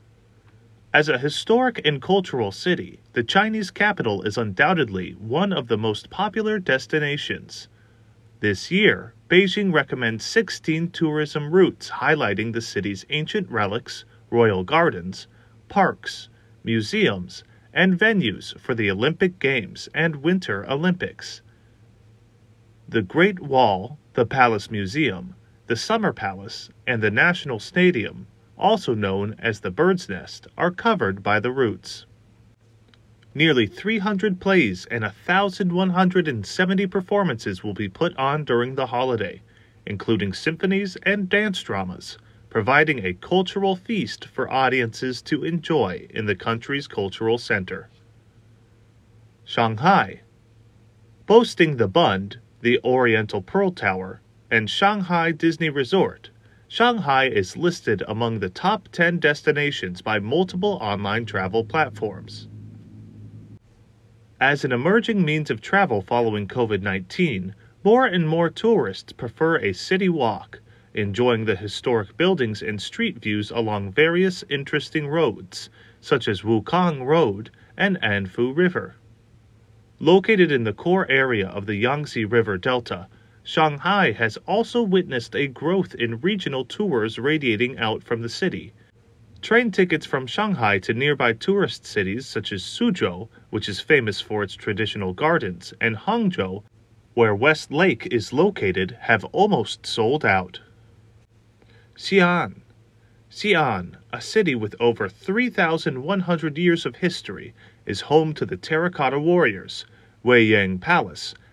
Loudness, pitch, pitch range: -22 LUFS, 115 Hz, 110-170 Hz